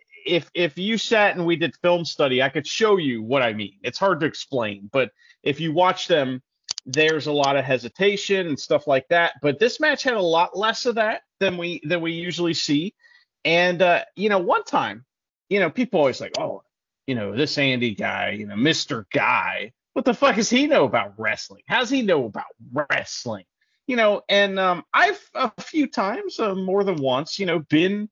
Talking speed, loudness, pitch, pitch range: 210 wpm, -22 LUFS, 180 Hz, 150-225 Hz